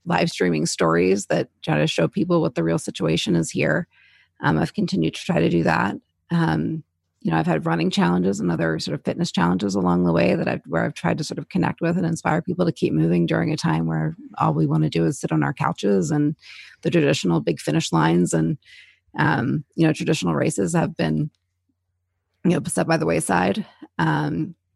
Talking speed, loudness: 215 wpm, -22 LUFS